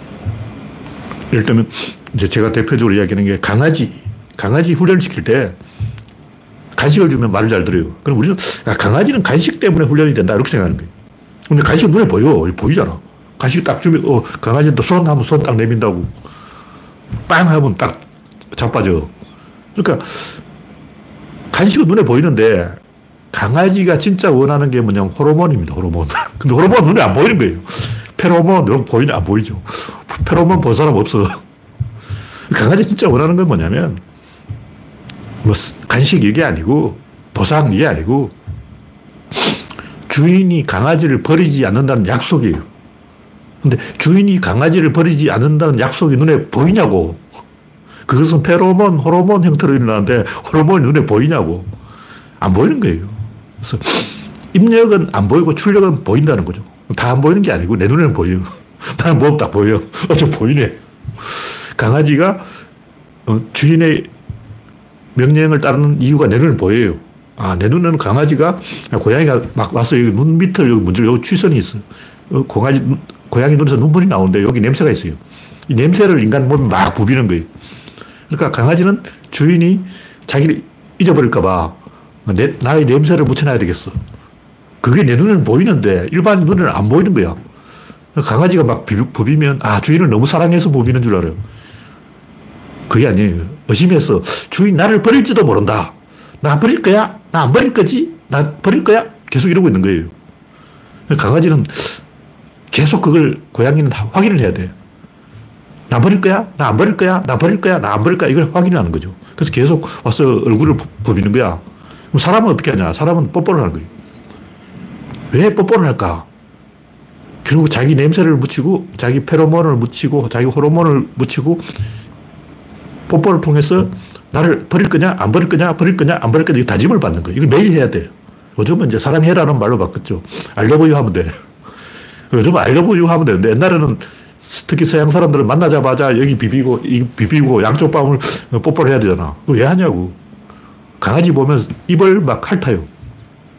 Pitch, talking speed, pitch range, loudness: 145 Hz, 335 characters per minute, 110-170 Hz, -12 LUFS